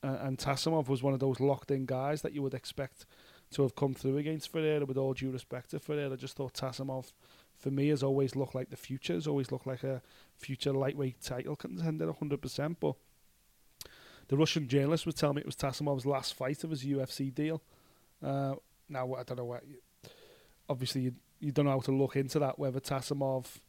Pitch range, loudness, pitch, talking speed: 130-145 Hz, -35 LUFS, 135 Hz, 205 wpm